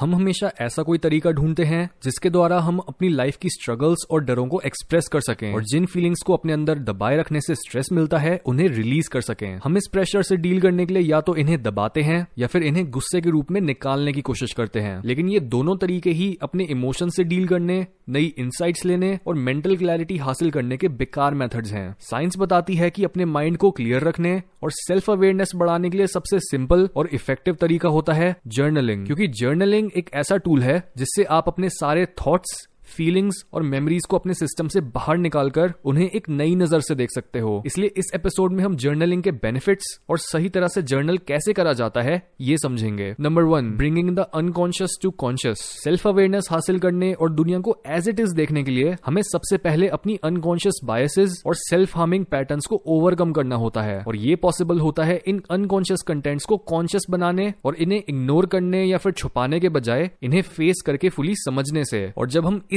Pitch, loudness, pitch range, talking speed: 170 Hz, -21 LUFS, 140-185 Hz, 205 wpm